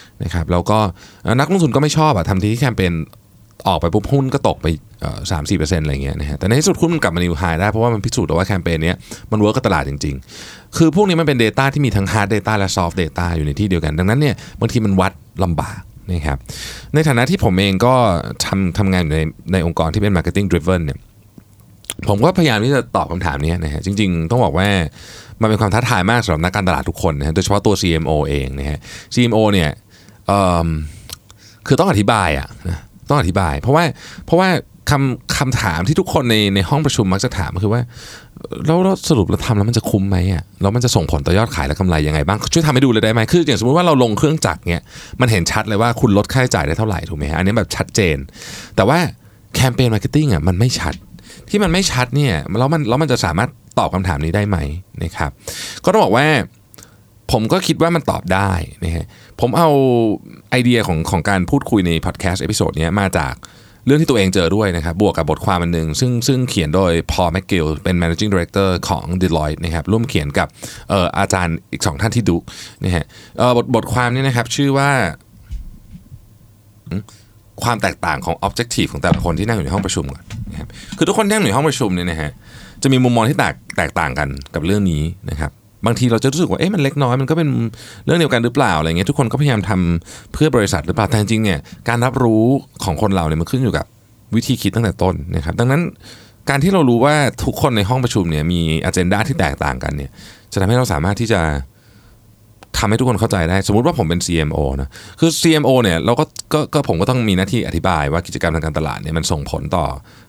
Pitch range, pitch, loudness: 85-120 Hz, 100 Hz, -16 LUFS